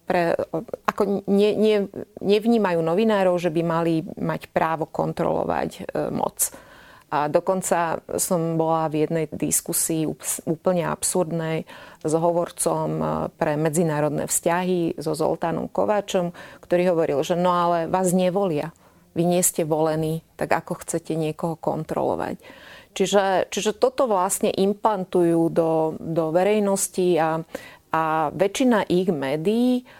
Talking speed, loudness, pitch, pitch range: 120 wpm, -23 LUFS, 175 Hz, 160-195 Hz